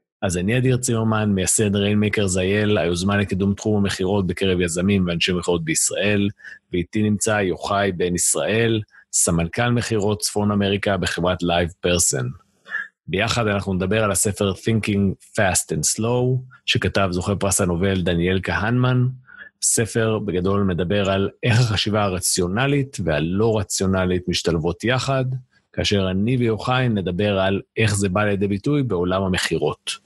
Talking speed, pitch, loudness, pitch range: 130 wpm, 100 Hz, -20 LUFS, 95-110 Hz